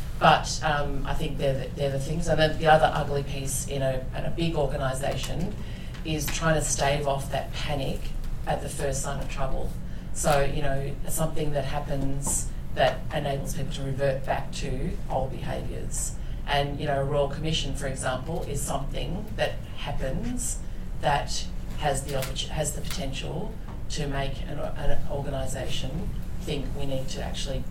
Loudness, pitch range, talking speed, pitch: -29 LUFS, 135-150 Hz, 165 wpm, 140 Hz